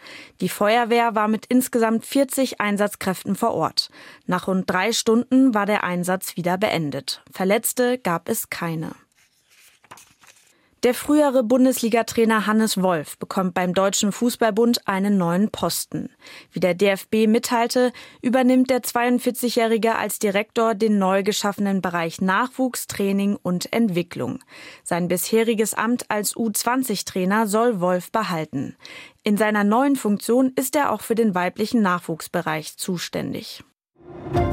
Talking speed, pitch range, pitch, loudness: 125 wpm, 185-235 Hz, 215 Hz, -21 LUFS